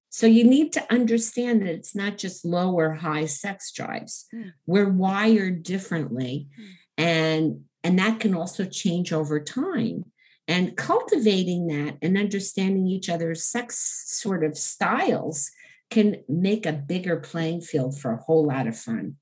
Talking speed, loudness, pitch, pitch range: 150 wpm, -24 LUFS, 180 Hz, 160-210 Hz